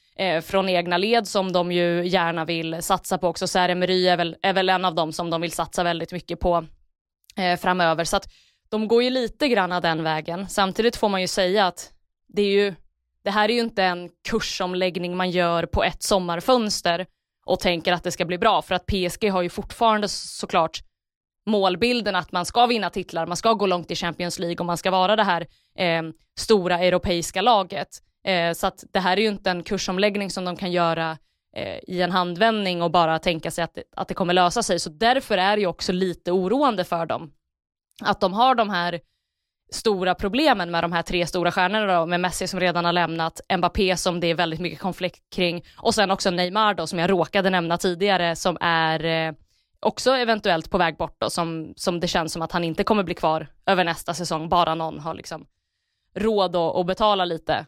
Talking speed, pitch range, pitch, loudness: 210 wpm, 170-195 Hz, 180 Hz, -22 LUFS